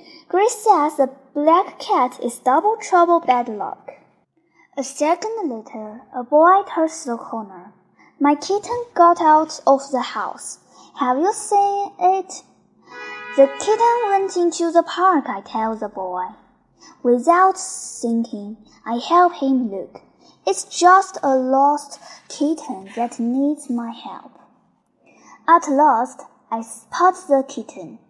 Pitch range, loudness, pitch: 245-355 Hz, -18 LUFS, 295 Hz